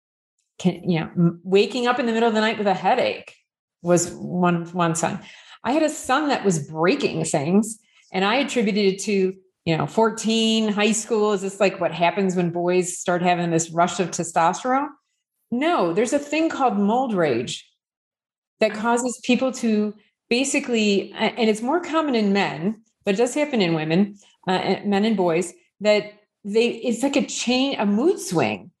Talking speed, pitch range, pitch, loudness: 180 wpm, 180-245 Hz, 210 Hz, -22 LUFS